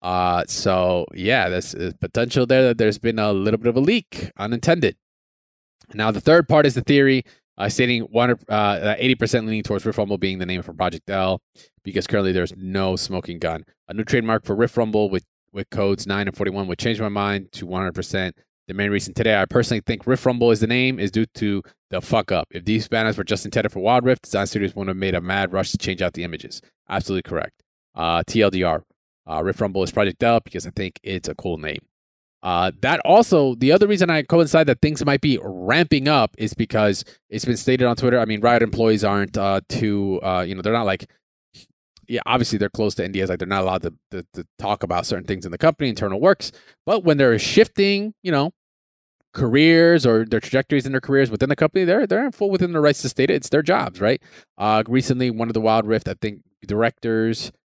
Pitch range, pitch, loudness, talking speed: 95-125 Hz, 110 Hz, -20 LUFS, 225 wpm